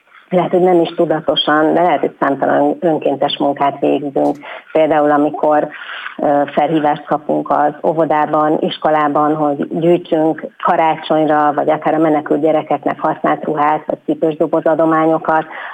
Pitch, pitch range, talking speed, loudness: 155 Hz, 150-160 Hz, 120 wpm, -14 LUFS